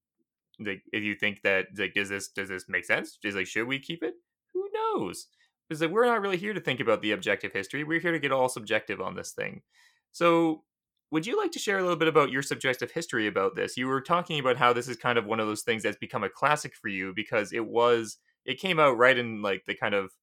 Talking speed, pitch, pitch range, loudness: 260 wpm, 135 Hz, 110-170 Hz, -28 LUFS